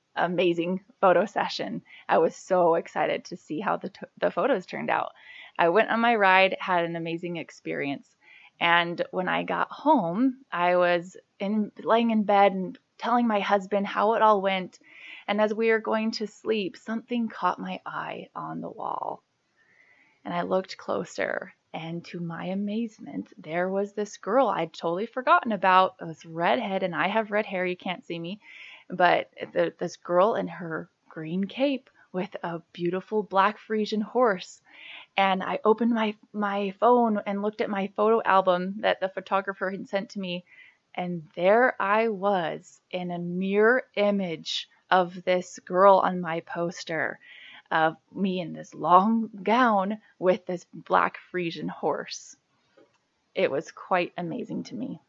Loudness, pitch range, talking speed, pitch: -26 LUFS, 175-215 Hz, 165 wpm, 195 Hz